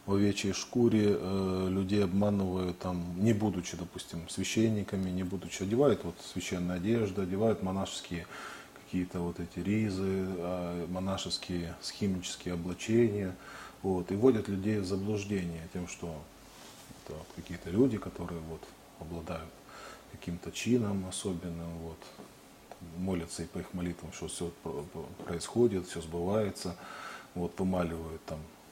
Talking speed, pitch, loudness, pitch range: 120 wpm, 95 Hz, -33 LUFS, 85-100 Hz